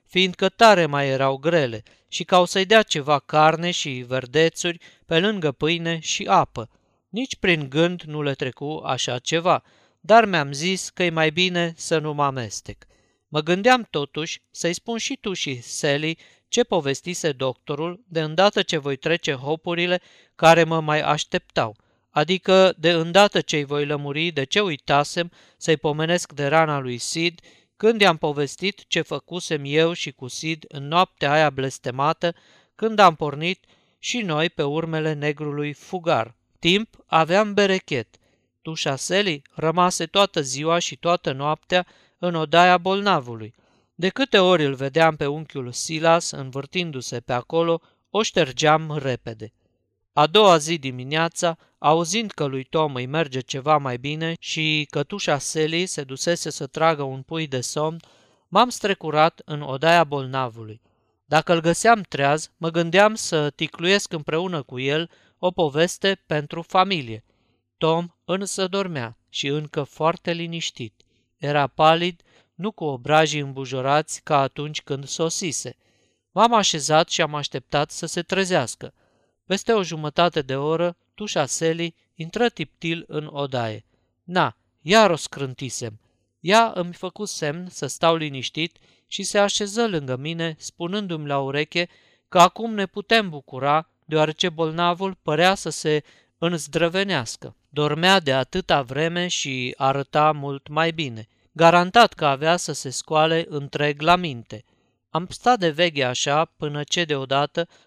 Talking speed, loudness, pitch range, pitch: 145 wpm, -22 LUFS, 140-175 Hz, 160 Hz